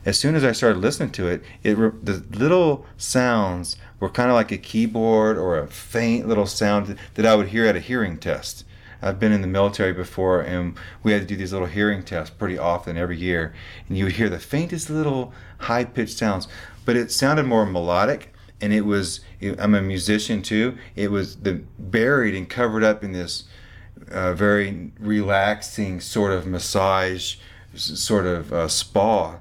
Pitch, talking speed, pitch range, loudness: 100 Hz, 185 wpm, 95-110 Hz, -22 LUFS